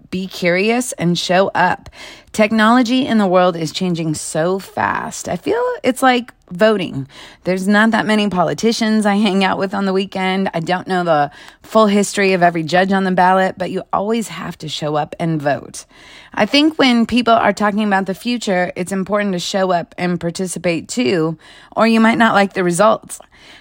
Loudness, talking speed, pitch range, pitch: -16 LUFS, 190 wpm, 180-215 Hz, 190 Hz